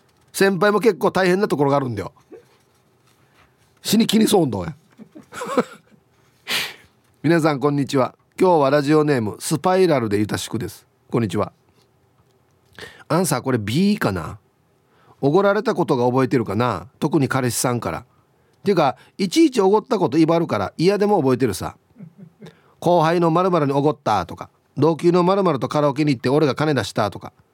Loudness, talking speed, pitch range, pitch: -19 LUFS, 335 characters per minute, 125-175 Hz, 145 Hz